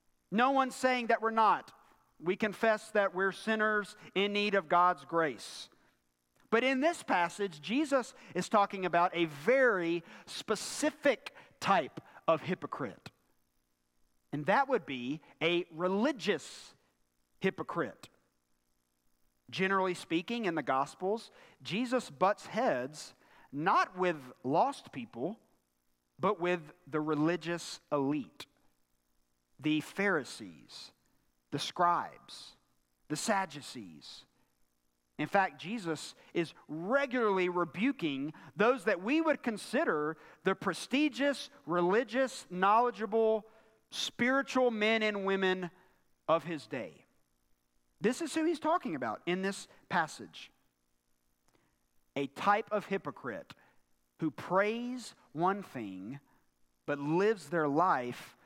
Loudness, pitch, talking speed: -33 LUFS, 180 Hz, 105 wpm